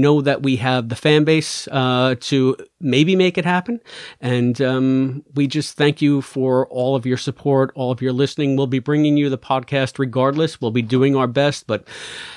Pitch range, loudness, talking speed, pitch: 130-145 Hz, -18 LUFS, 205 wpm, 135 Hz